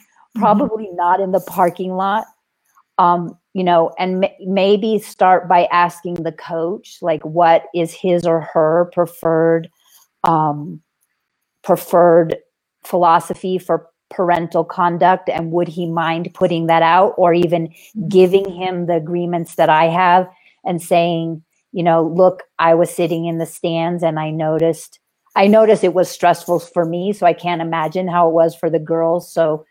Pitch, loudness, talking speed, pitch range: 175 Hz, -16 LUFS, 160 wpm, 165-185 Hz